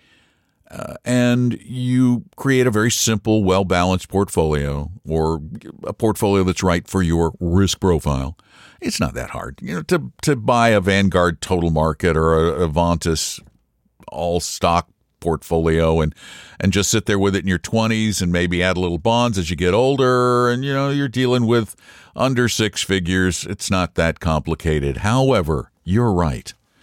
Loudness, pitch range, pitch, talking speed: -19 LUFS, 85-115 Hz, 95 Hz, 165 wpm